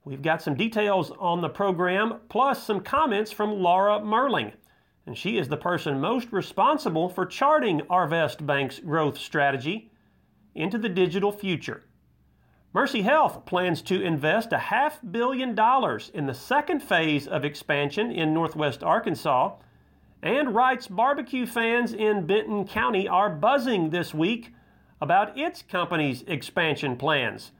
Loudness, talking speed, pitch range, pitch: -25 LUFS, 140 wpm, 155-220 Hz, 185 Hz